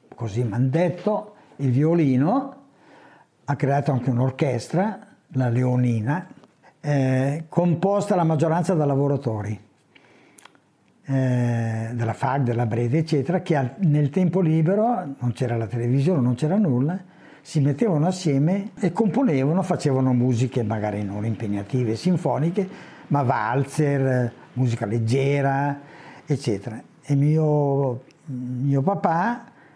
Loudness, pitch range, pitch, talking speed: -23 LUFS, 125-170 Hz, 140 Hz, 110 wpm